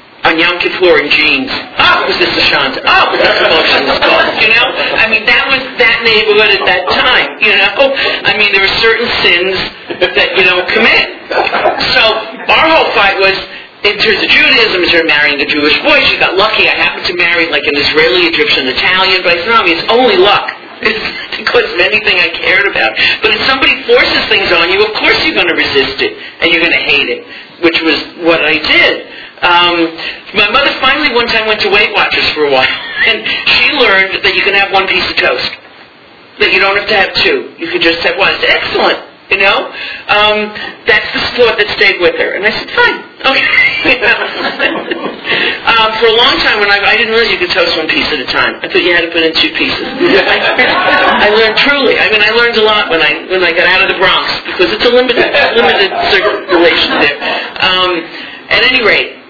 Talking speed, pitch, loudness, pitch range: 215 wpm, 210 Hz, -8 LUFS, 175-265 Hz